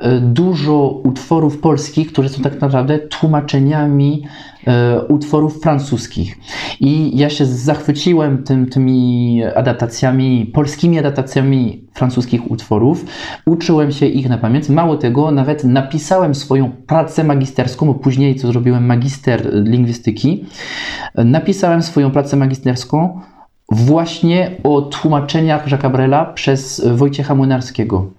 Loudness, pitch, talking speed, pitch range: -14 LUFS, 140 Hz, 110 wpm, 125-150 Hz